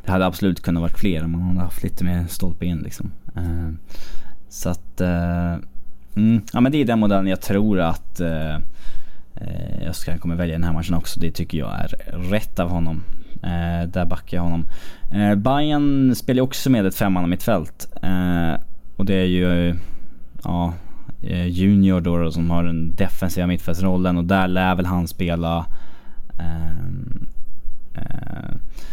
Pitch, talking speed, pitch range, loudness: 85 Hz, 170 wpm, 85-95 Hz, -22 LUFS